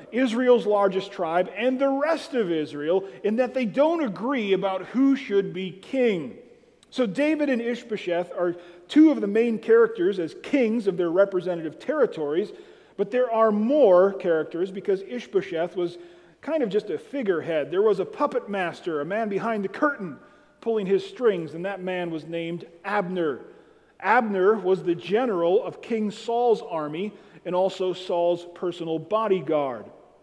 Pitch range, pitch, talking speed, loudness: 180-260 Hz, 205 Hz, 155 wpm, -24 LUFS